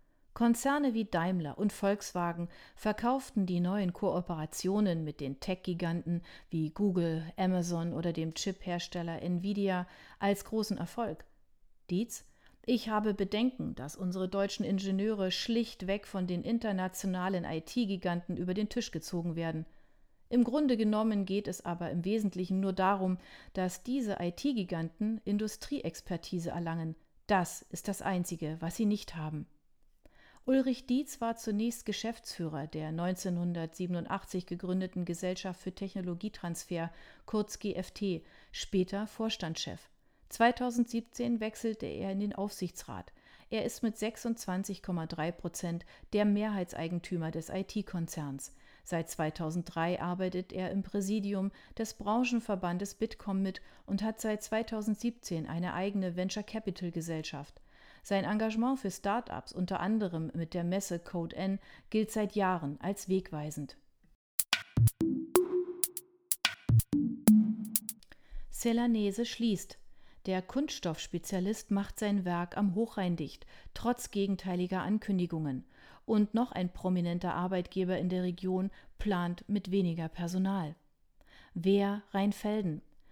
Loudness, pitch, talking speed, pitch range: -34 LUFS, 190 Hz, 110 wpm, 175-215 Hz